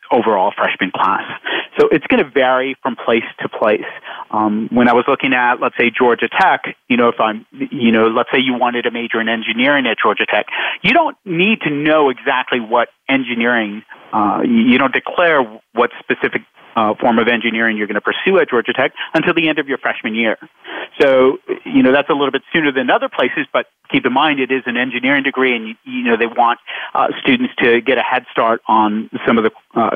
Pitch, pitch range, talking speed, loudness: 130 Hz, 115-160 Hz, 220 wpm, -15 LUFS